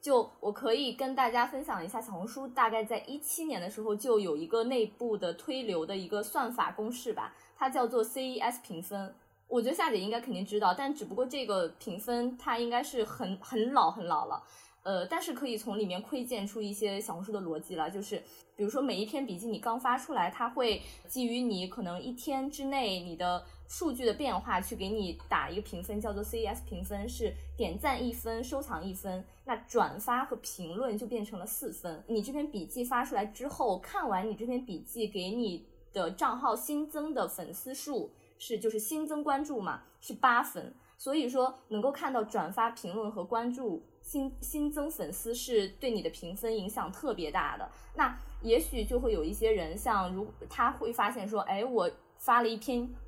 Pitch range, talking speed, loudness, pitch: 205-265 Hz, 295 characters per minute, -34 LUFS, 235 Hz